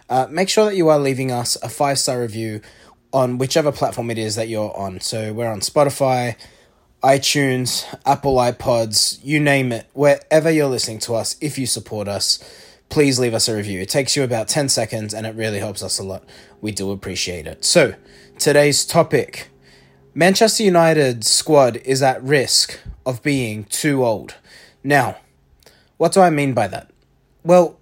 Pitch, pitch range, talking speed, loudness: 125 Hz, 110-145 Hz, 175 wpm, -18 LUFS